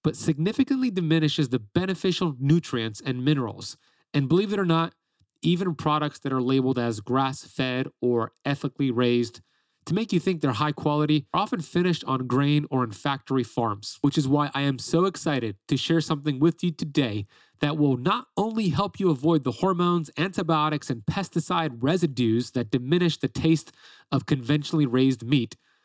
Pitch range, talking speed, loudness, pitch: 130-170 Hz, 170 wpm, -25 LUFS, 150 Hz